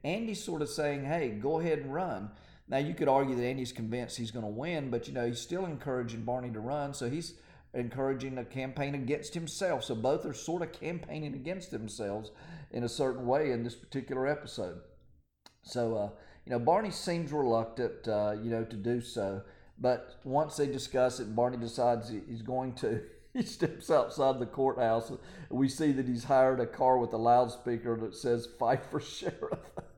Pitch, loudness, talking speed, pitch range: 125 Hz, -33 LUFS, 190 wpm, 115-145 Hz